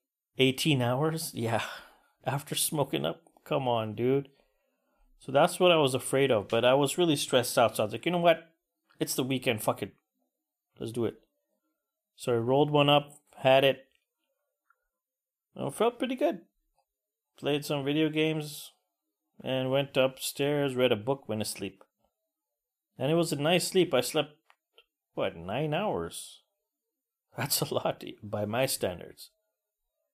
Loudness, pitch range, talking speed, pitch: -29 LUFS, 130-175 Hz, 155 wpm, 145 Hz